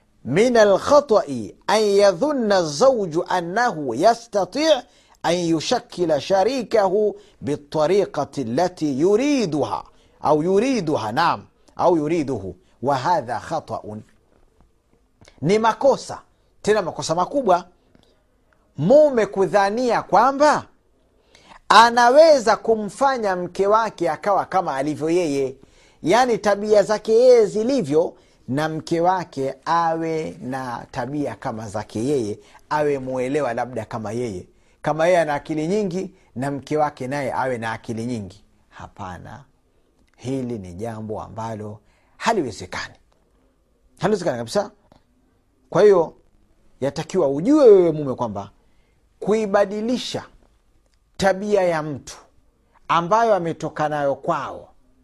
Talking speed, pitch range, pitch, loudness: 100 wpm, 135-215 Hz, 175 Hz, -20 LUFS